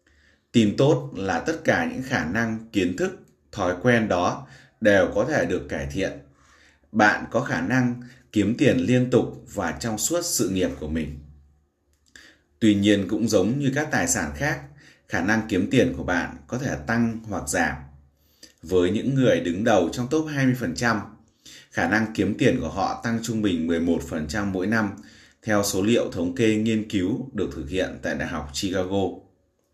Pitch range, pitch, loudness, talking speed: 80-120 Hz, 105 Hz, -24 LUFS, 180 wpm